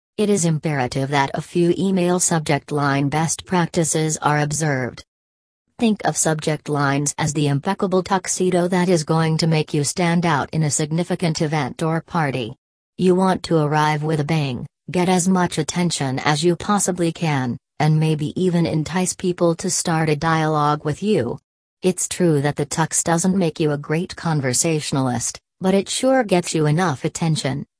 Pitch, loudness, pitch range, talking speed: 160 Hz, -20 LUFS, 150-175 Hz, 170 wpm